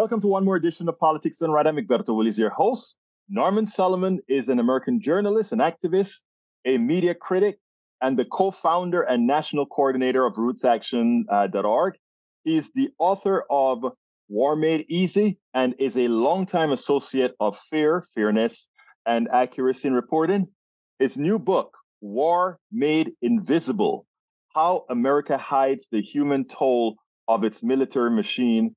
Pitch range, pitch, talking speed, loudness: 130-190 Hz, 150 Hz, 140 wpm, -23 LUFS